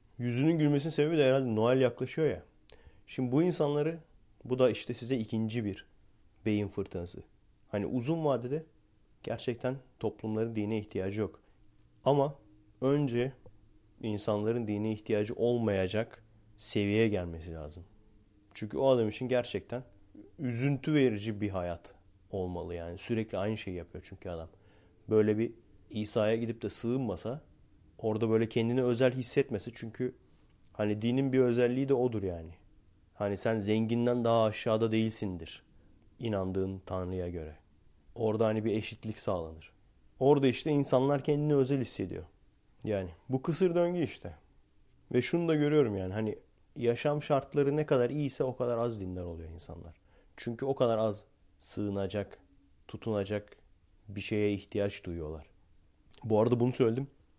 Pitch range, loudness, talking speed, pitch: 100-125 Hz, -32 LUFS, 135 wpm, 110 Hz